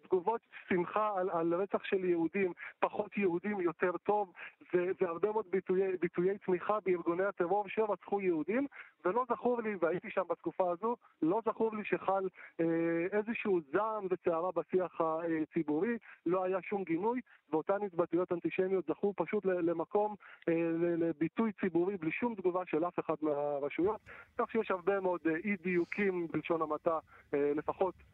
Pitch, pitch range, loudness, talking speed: 185 Hz, 170-205 Hz, -34 LUFS, 145 wpm